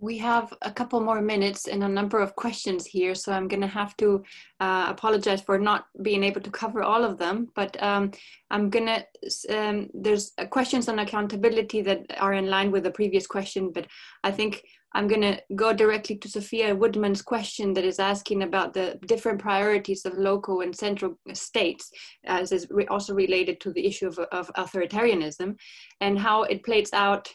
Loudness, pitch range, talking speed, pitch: -26 LUFS, 195-215 Hz, 190 wpm, 200 Hz